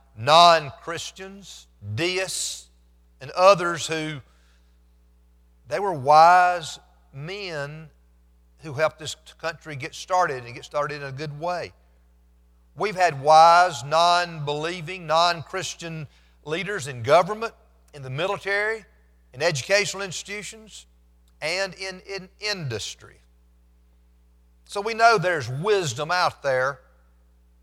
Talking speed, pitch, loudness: 110 wpm, 155 Hz, -22 LUFS